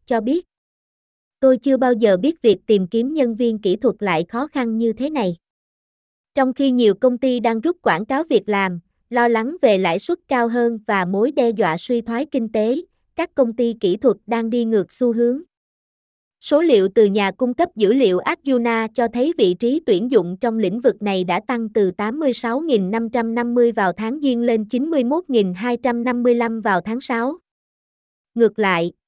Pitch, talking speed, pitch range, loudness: 235 Hz, 185 wpm, 215-260 Hz, -19 LUFS